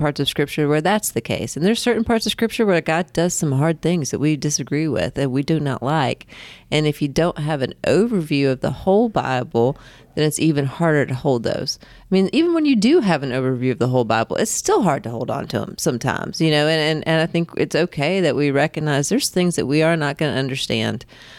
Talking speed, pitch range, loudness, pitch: 250 wpm, 135-170 Hz, -19 LUFS, 155 Hz